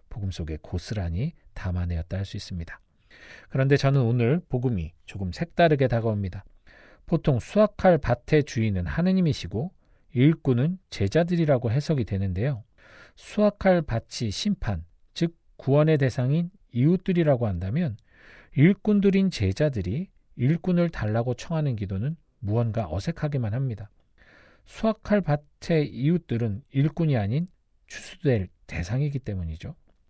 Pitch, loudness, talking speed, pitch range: 130 Hz, -26 LUFS, 300 characters per minute, 105-165 Hz